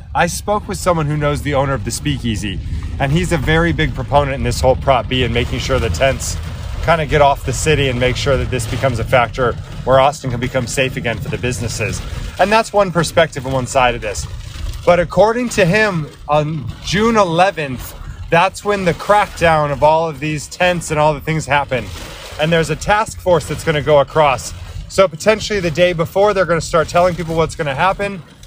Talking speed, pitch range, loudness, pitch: 220 wpm, 125-170 Hz, -16 LUFS, 145 Hz